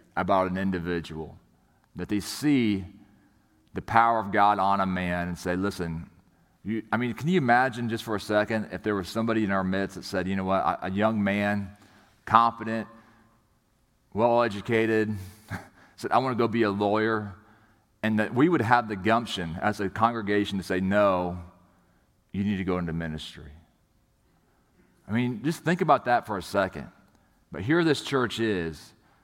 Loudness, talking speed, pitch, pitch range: -26 LUFS, 175 wpm, 105 Hz, 95-115 Hz